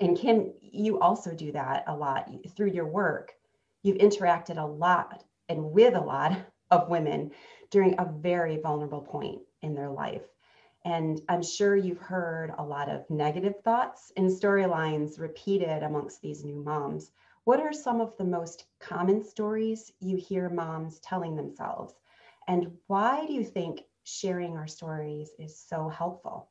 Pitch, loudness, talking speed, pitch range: 175 Hz, -29 LUFS, 160 wpm, 160-200 Hz